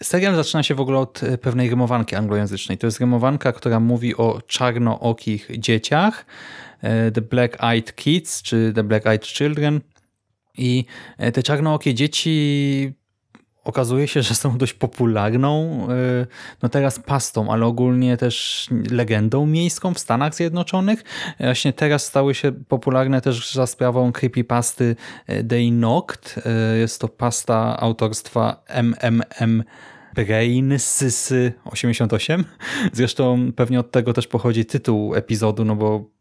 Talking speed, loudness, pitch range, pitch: 125 wpm, -20 LUFS, 115-135 Hz, 125 Hz